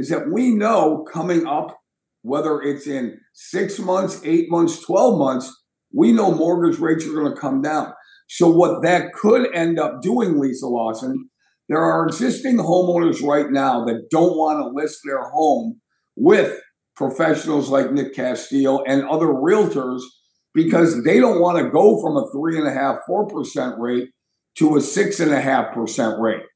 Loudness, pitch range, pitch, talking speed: -19 LUFS, 140-180 Hz, 160 Hz, 175 wpm